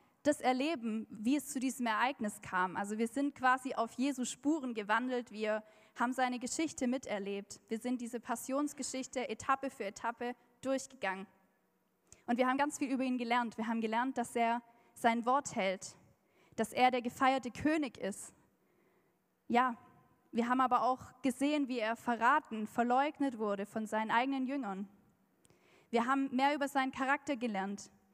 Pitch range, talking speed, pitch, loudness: 225-265 Hz, 155 wpm, 245 Hz, -35 LUFS